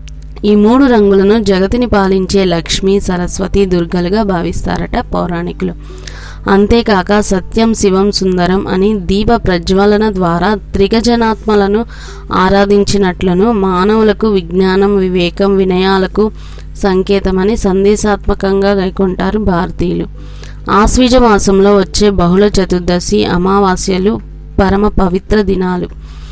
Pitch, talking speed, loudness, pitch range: 195 Hz, 85 wpm, -11 LUFS, 185-210 Hz